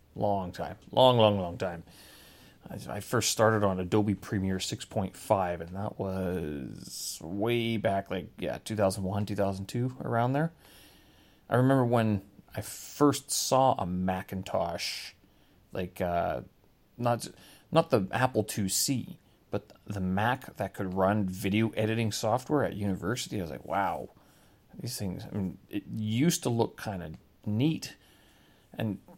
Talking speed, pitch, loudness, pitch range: 150 wpm, 100 Hz, -30 LUFS, 95-115 Hz